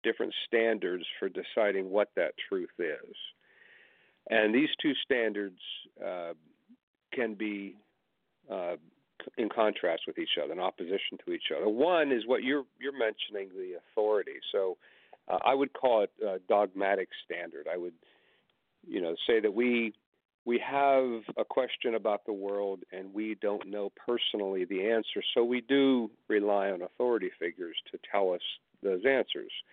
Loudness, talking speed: -31 LUFS, 155 wpm